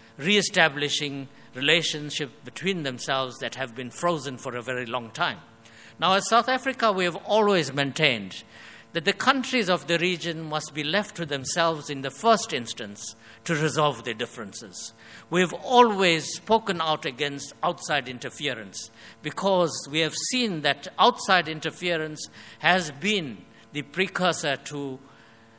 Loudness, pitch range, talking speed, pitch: -25 LUFS, 135-180 Hz, 140 wpm, 155 Hz